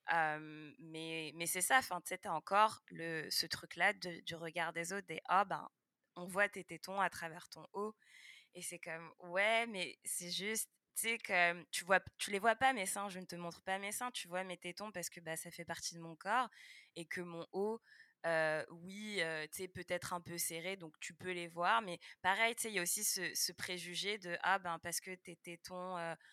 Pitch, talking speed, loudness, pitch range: 180 Hz, 235 wpm, -39 LUFS, 170-195 Hz